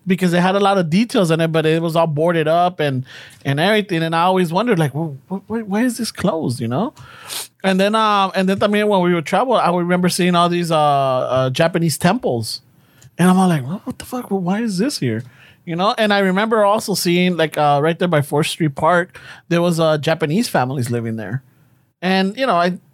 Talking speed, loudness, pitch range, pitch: 240 wpm, -17 LUFS, 150-190 Hz, 175 Hz